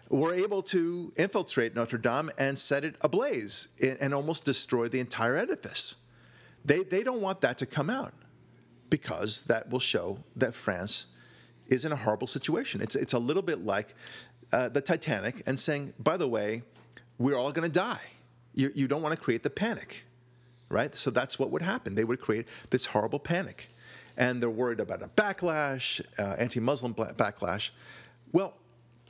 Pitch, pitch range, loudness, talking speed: 135 Hz, 120-160 Hz, -30 LUFS, 175 wpm